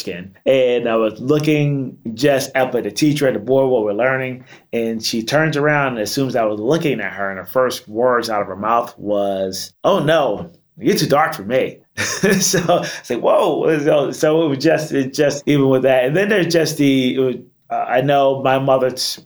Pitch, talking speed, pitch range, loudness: 130 Hz, 220 wpm, 115-145 Hz, -17 LUFS